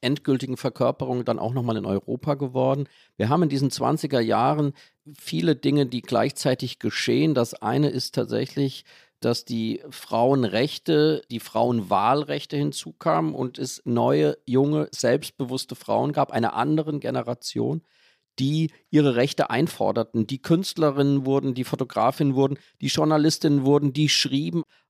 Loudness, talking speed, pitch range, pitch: -24 LUFS, 130 wpm, 125-150 Hz, 135 Hz